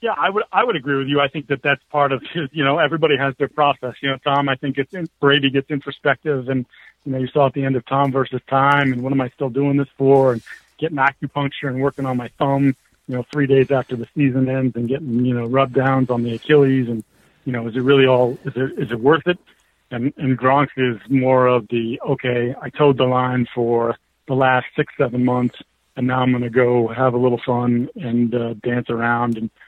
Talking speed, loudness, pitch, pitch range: 245 wpm, -19 LUFS, 130 Hz, 125-140 Hz